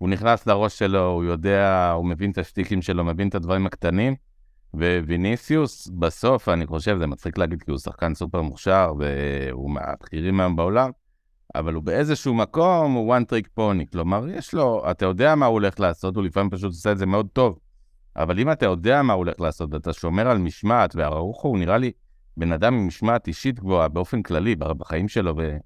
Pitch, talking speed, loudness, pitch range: 95 Hz, 195 wpm, -22 LUFS, 85-110 Hz